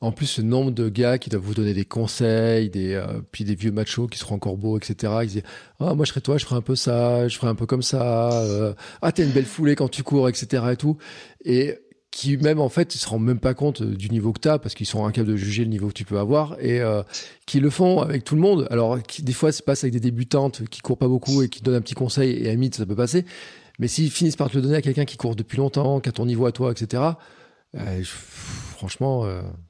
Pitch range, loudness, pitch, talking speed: 110-140 Hz, -22 LUFS, 125 Hz, 285 wpm